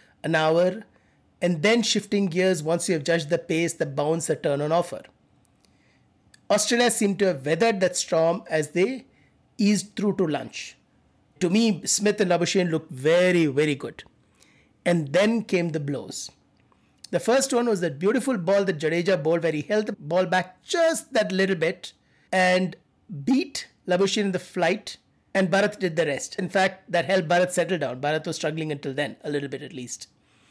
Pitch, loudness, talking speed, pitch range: 180 Hz, -24 LUFS, 185 wpm, 165-200 Hz